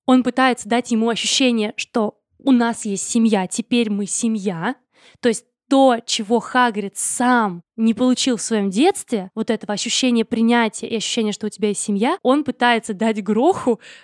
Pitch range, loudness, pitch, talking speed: 215-245 Hz, -19 LUFS, 230 Hz, 165 wpm